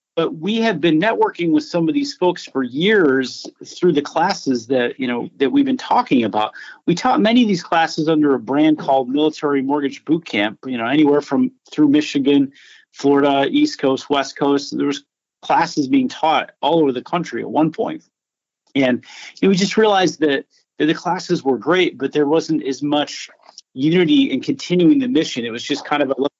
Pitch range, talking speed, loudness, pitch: 140-180 Hz, 200 wpm, -18 LUFS, 150 Hz